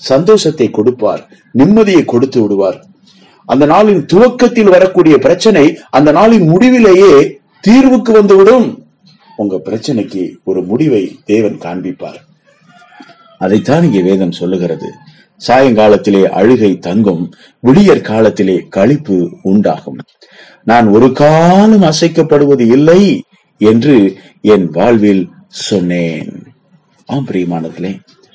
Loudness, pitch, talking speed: -9 LUFS, 145 Hz, 90 wpm